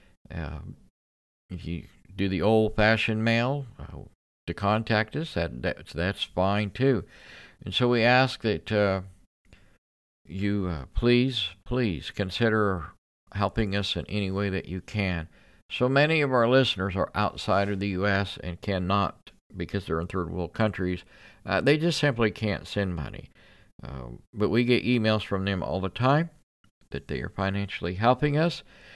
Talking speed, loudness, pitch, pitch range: 155 wpm, -26 LUFS, 100 Hz, 90-115 Hz